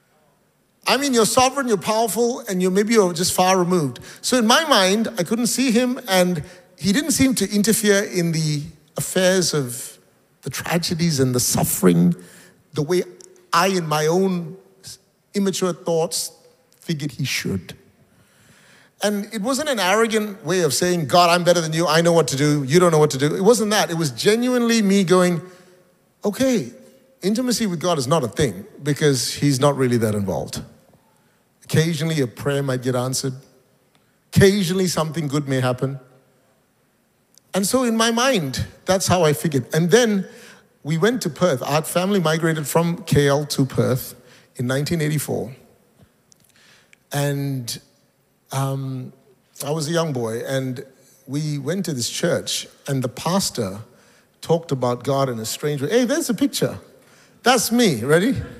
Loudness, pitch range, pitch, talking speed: -20 LUFS, 140-195 Hz, 165 Hz, 160 wpm